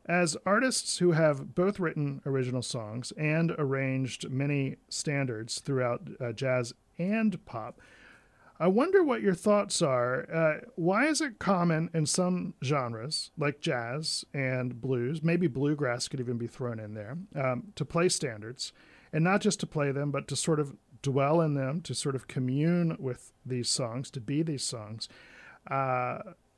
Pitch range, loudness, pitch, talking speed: 130-170 Hz, -30 LUFS, 145 Hz, 160 wpm